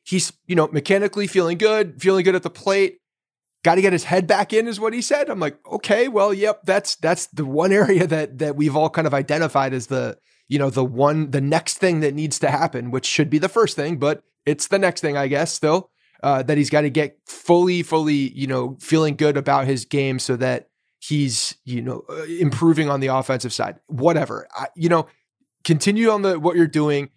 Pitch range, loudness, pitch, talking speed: 140-185 Hz, -20 LUFS, 155 Hz, 225 wpm